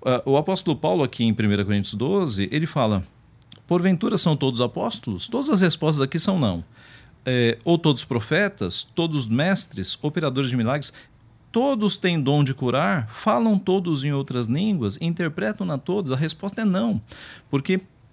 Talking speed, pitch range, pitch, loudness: 150 wpm, 120-180 Hz, 140 Hz, -22 LUFS